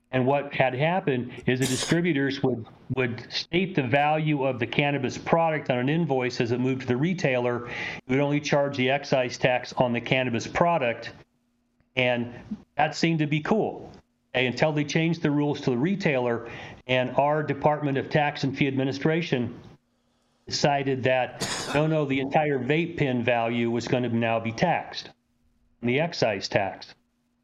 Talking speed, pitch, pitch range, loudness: 165 wpm, 135 Hz, 125-150 Hz, -25 LUFS